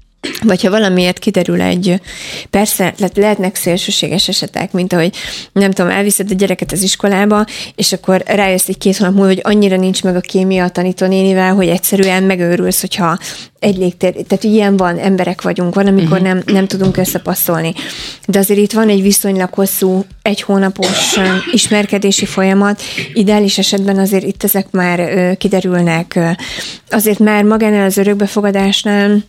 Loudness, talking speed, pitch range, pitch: -12 LUFS, 150 wpm, 185-205 Hz, 195 Hz